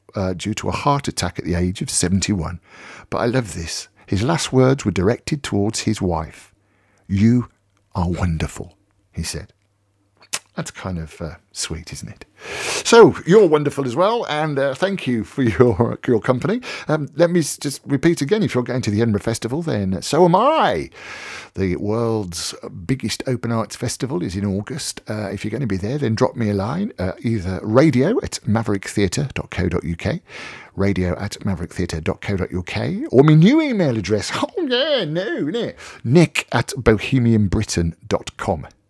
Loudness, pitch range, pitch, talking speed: -19 LUFS, 95-135 Hz, 110 Hz, 165 wpm